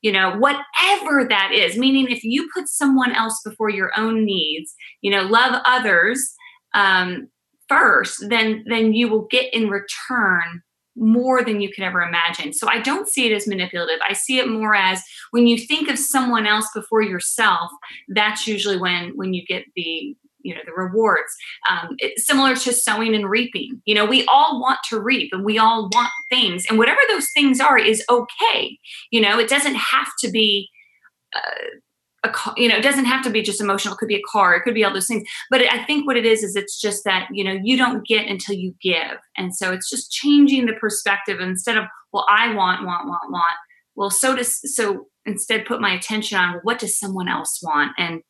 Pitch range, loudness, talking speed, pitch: 195-250 Hz, -18 LUFS, 210 wpm, 220 Hz